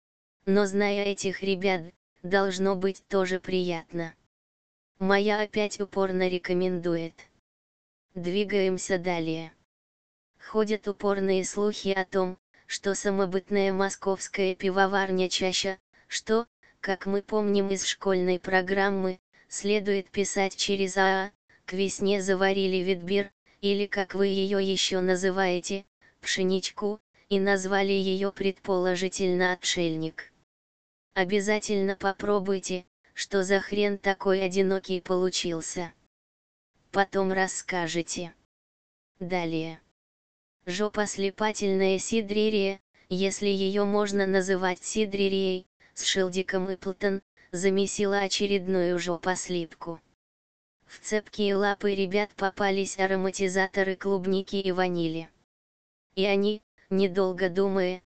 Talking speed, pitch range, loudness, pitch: 95 wpm, 180-200 Hz, -27 LUFS, 190 Hz